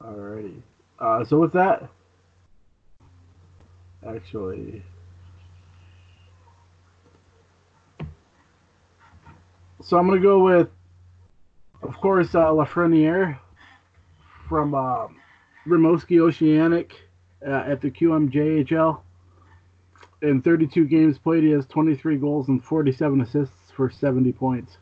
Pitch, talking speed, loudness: 105 Hz, 90 wpm, -21 LUFS